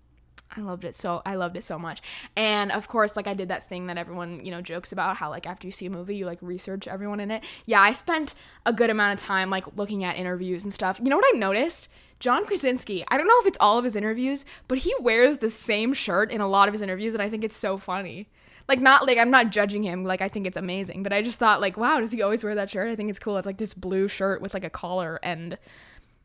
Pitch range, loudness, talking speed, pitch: 185-220 Hz, -25 LUFS, 280 wpm, 200 Hz